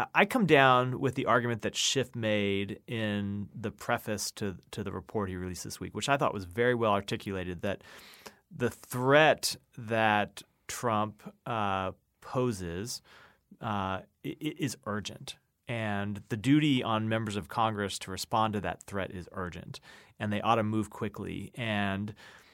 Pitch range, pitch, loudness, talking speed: 100-120 Hz, 105 Hz, -31 LUFS, 155 wpm